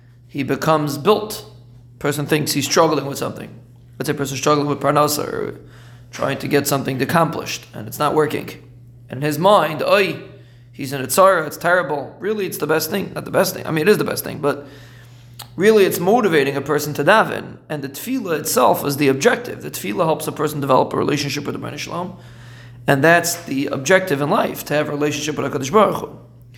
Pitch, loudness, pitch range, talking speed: 145 Hz, -18 LUFS, 130-160 Hz, 210 wpm